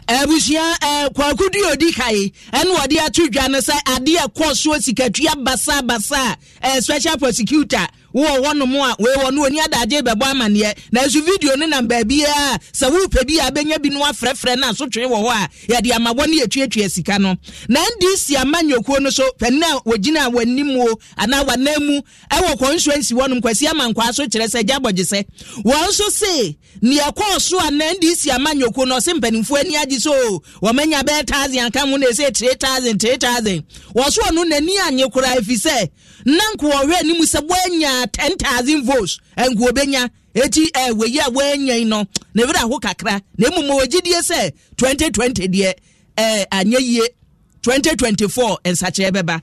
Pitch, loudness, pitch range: 265 Hz, -16 LUFS, 235-295 Hz